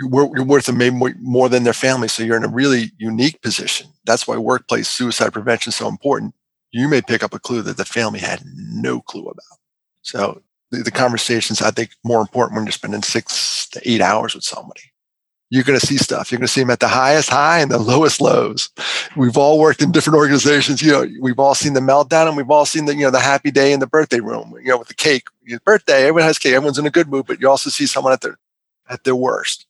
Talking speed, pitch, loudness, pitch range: 245 wpm, 130 Hz, -16 LUFS, 120-145 Hz